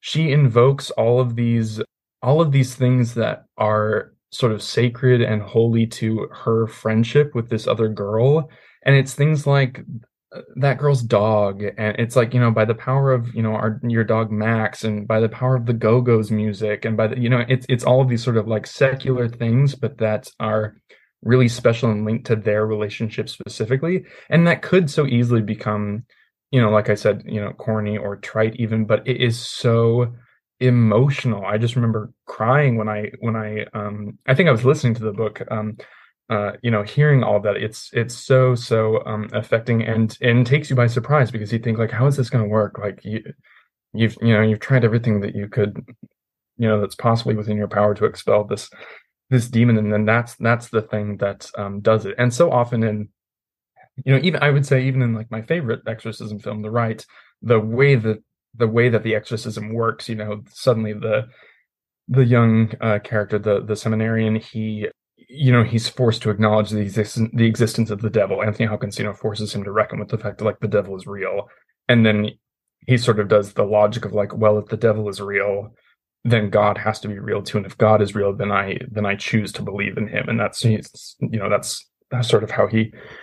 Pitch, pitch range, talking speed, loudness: 115 Hz, 105-125 Hz, 215 wpm, -20 LUFS